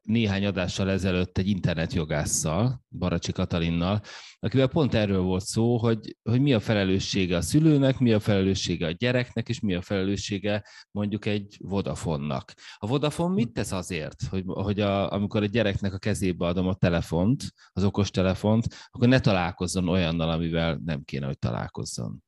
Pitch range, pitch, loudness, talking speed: 90-115 Hz, 100 Hz, -26 LUFS, 155 wpm